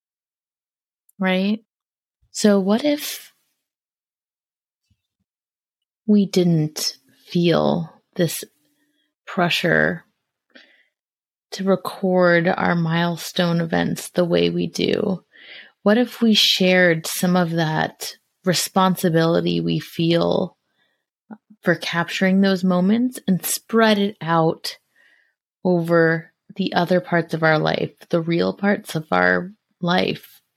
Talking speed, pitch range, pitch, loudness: 95 wpm, 165-205 Hz, 180 Hz, -20 LUFS